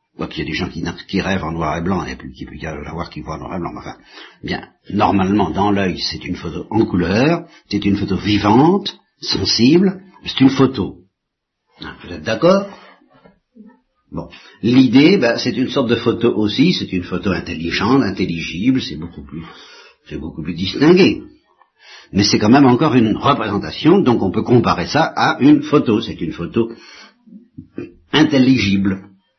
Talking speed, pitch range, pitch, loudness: 180 wpm, 90-135 Hz, 100 Hz, -16 LUFS